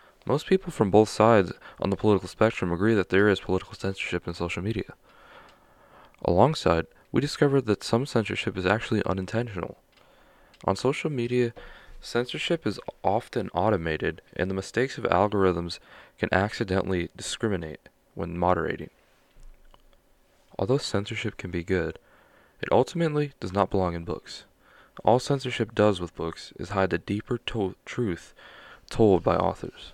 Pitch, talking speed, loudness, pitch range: 105 Hz, 140 wpm, -26 LUFS, 90-120 Hz